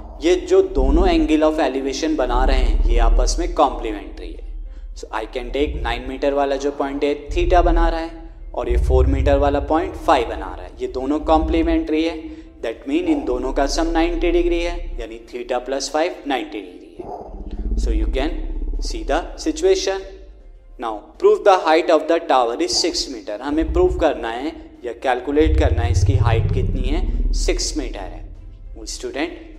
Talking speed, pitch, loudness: 180 wpm, 160 Hz, -20 LUFS